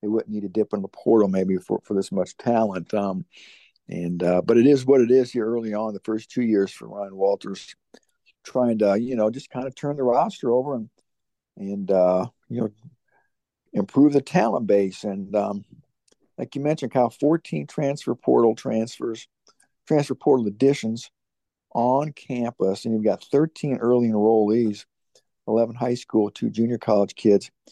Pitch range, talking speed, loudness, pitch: 100-125 Hz, 180 wpm, -23 LUFS, 115 Hz